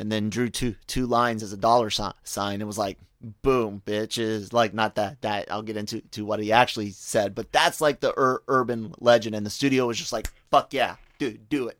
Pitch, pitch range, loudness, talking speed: 110 Hz, 105-120 Hz, -25 LUFS, 235 wpm